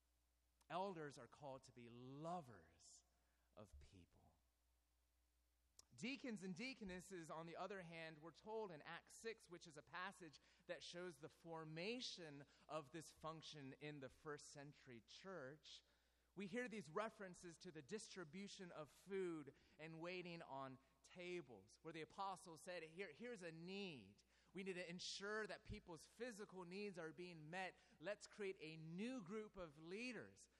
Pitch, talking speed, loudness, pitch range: 165 Hz, 145 wpm, -55 LUFS, 140-190 Hz